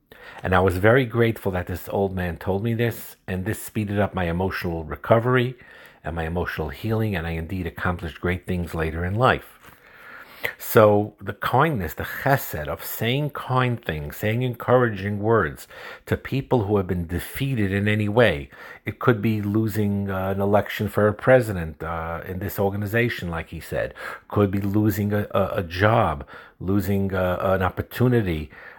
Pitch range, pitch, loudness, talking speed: 90-110 Hz, 100 Hz, -23 LUFS, 165 wpm